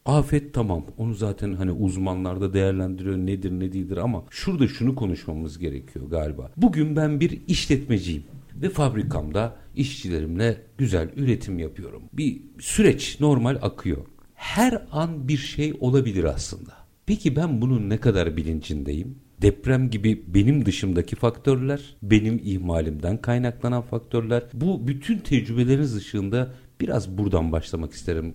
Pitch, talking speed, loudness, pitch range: 115 Hz, 125 wpm, -24 LUFS, 95-135 Hz